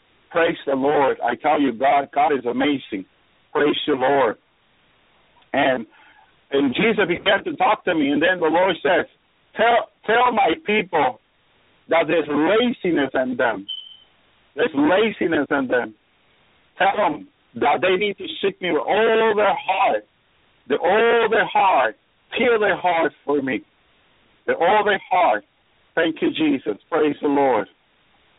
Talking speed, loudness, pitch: 150 wpm, -20 LUFS, 210 Hz